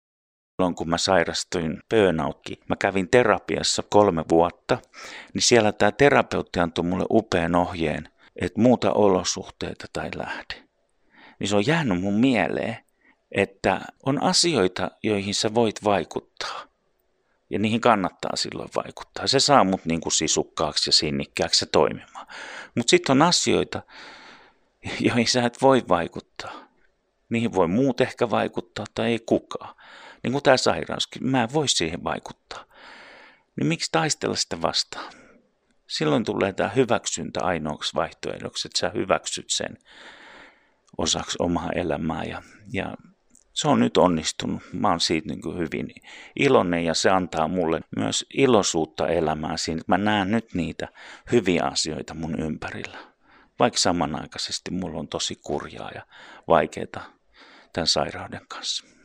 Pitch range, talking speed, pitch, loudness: 85-120 Hz, 135 wpm, 100 Hz, -23 LUFS